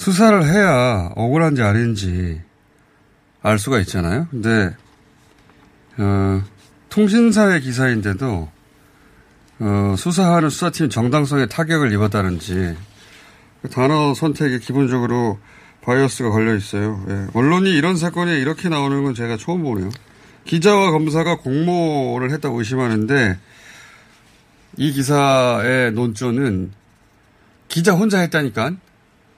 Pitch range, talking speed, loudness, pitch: 105-155 Hz, 260 characters per minute, -18 LUFS, 130 Hz